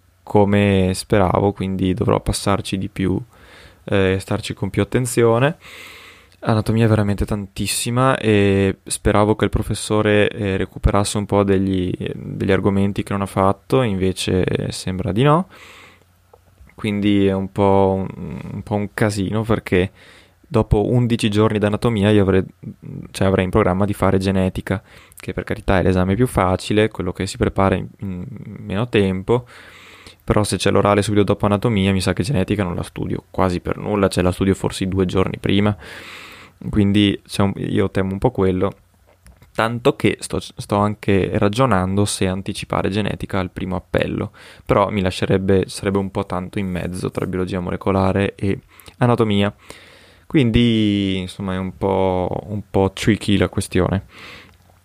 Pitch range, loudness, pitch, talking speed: 95-105 Hz, -19 LUFS, 100 Hz, 155 wpm